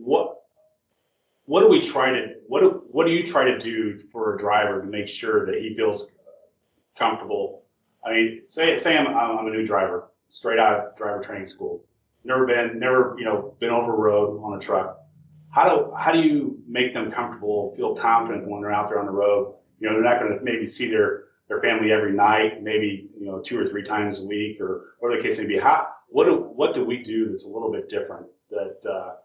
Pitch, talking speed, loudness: 130 Hz, 225 wpm, -22 LUFS